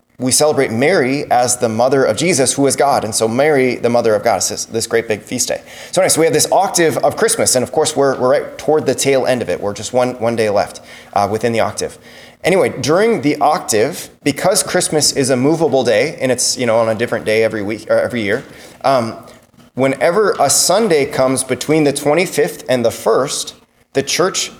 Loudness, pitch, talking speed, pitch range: -14 LUFS, 130 Hz, 225 wpm, 115-150 Hz